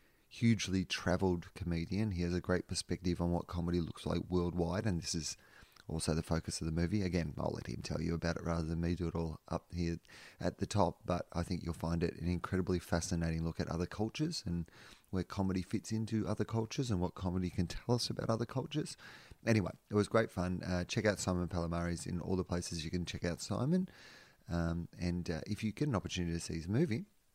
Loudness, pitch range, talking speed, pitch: -37 LUFS, 85-105 Hz, 225 wpm, 90 Hz